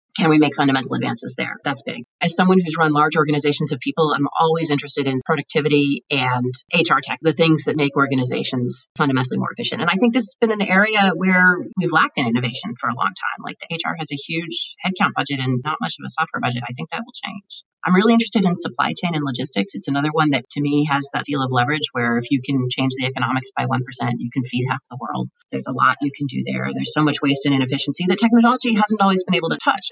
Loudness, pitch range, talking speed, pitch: -19 LUFS, 130-175 Hz, 250 wpm, 145 Hz